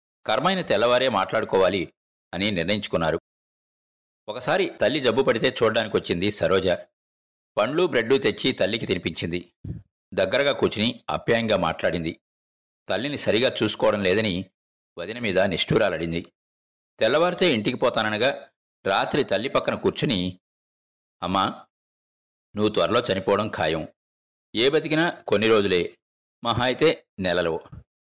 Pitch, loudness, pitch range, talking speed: 85 Hz, -23 LUFS, 65-105 Hz, 100 wpm